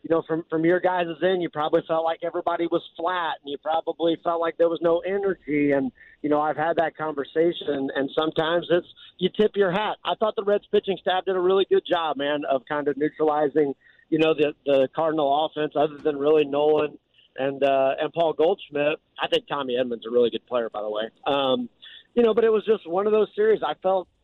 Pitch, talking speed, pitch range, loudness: 160 Hz, 230 wpm, 145-175 Hz, -24 LUFS